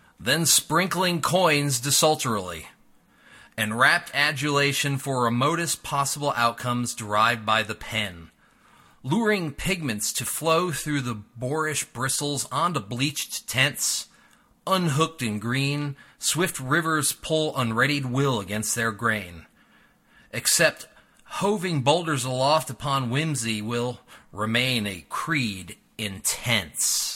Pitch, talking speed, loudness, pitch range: 135 Hz, 105 wpm, -24 LUFS, 115-155 Hz